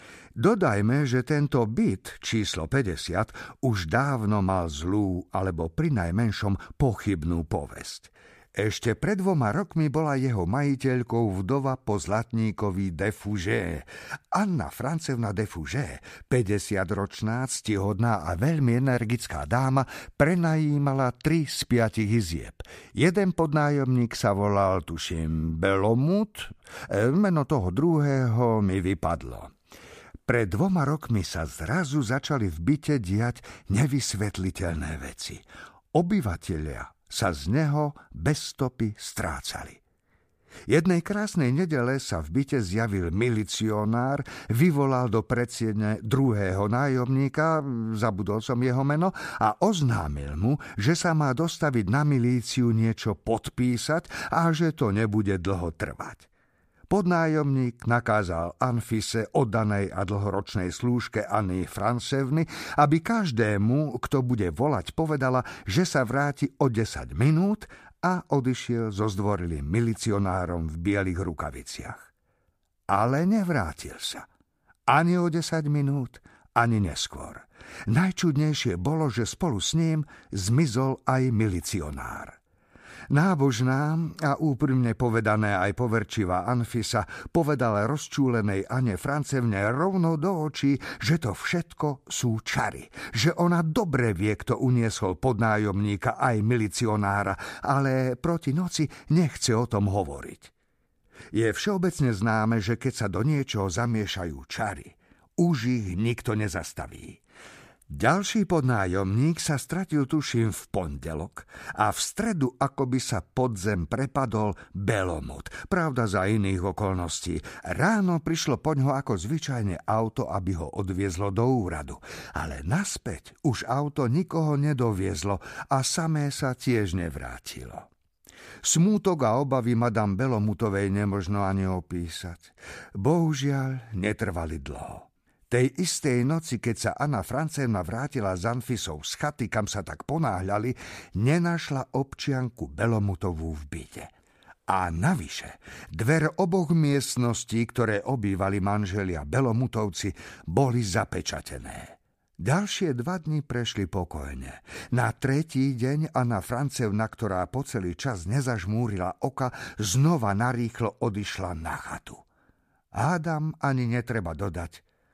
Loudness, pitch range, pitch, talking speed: -27 LUFS, 100-140 Hz, 120 Hz, 110 wpm